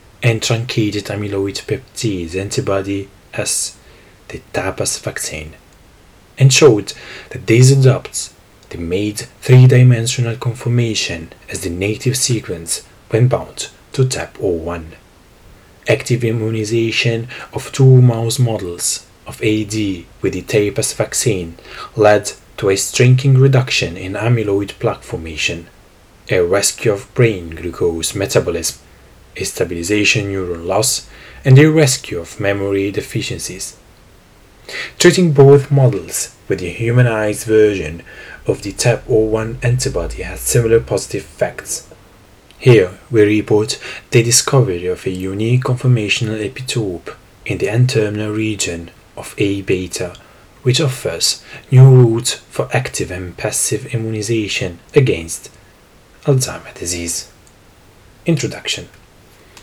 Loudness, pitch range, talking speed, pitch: -15 LUFS, 95-125 Hz, 110 wpm, 110 Hz